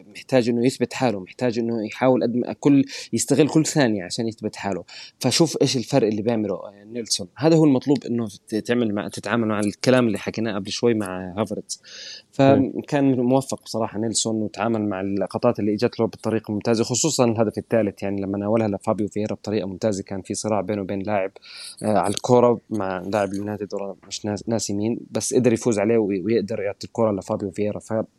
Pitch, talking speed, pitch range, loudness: 110 Hz, 175 wpm, 100-120 Hz, -22 LUFS